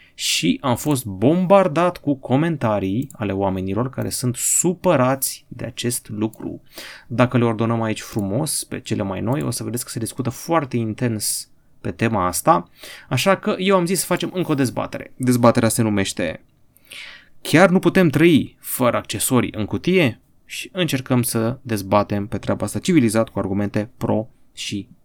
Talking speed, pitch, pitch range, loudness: 160 wpm, 120 Hz, 110-145 Hz, -20 LUFS